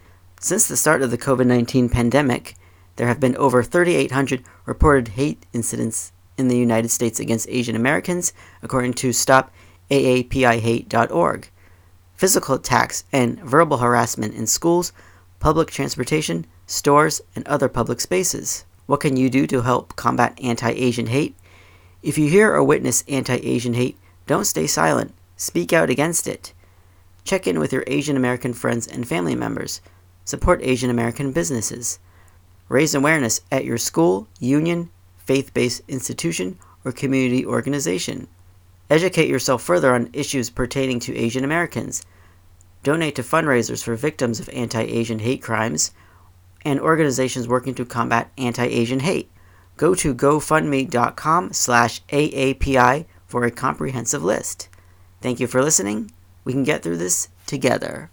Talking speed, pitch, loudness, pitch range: 135 wpm, 120 Hz, -20 LUFS, 95-135 Hz